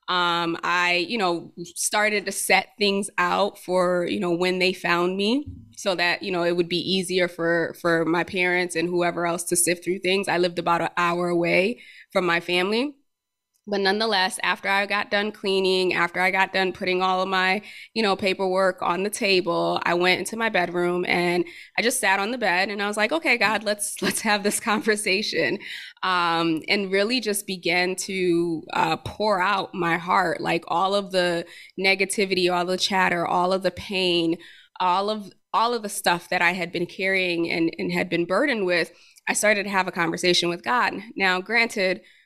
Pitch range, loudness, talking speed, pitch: 175-200 Hz, -23 LUFS, 195 wpm, 185 Hz